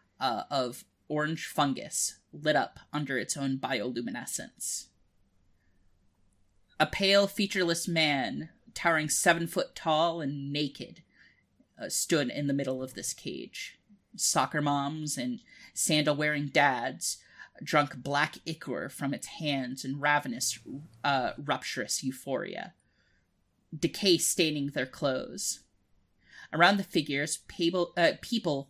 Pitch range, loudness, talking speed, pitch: 130-170 Hz, -30 LUFS, 110 wpm, 150 Hz